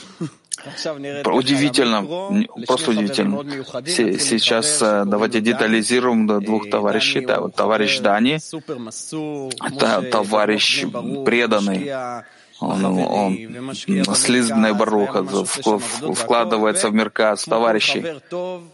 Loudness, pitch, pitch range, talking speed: -19 LUFS, 120 Hz, 110-145 Hz, 70 wpm